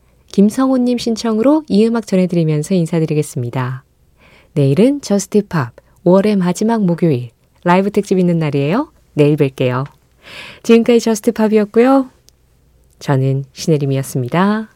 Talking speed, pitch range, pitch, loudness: 315 characters per minute, 140-220 Hz, 180 Hz, -15 LUFS